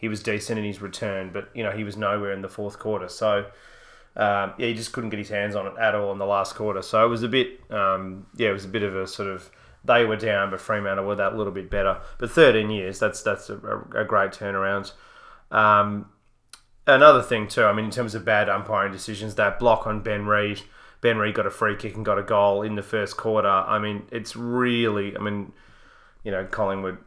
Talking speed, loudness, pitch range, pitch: 235 wpm, -23 LUFS, 100-110 Hz, 105 Hz